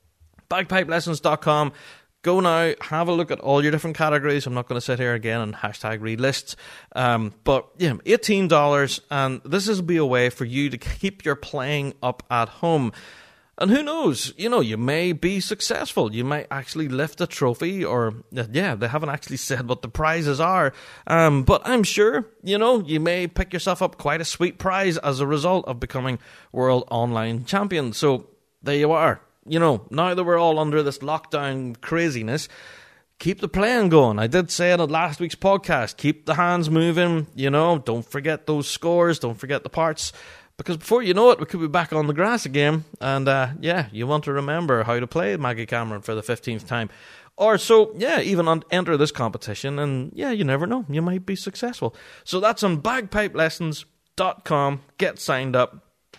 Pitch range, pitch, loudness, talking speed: 130-175 Hz, 155 Hz, -22 LUFS, 195 wpm